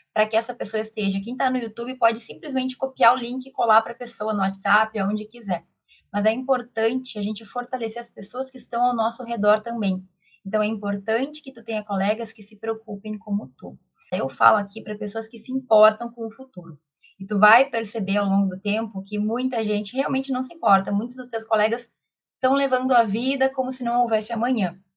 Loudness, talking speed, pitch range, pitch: -23 LUFS, 210 wpm, 210-245 Hz, 225 Hz